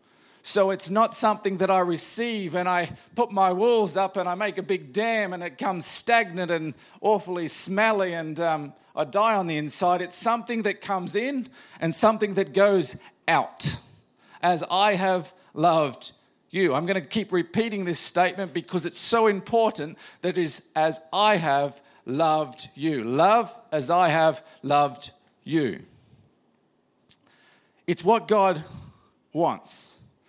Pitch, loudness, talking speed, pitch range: 185 Hz, -24 LUFS, 155 wpm, 165-210 Hz